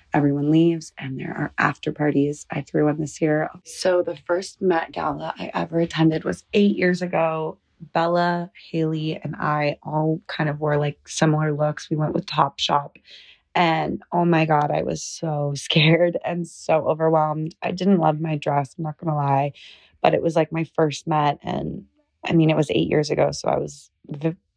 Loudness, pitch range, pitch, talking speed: -22 LUFS, 150-170 Hz, 160 Hz, 190 wpm